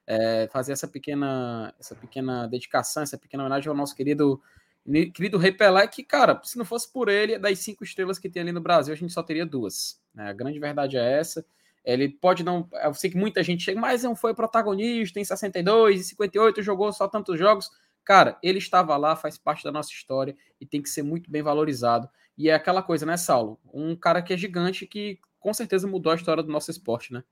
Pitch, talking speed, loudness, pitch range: 170 Hz, 215 wpm, -24 LUFS, 140-200 Hz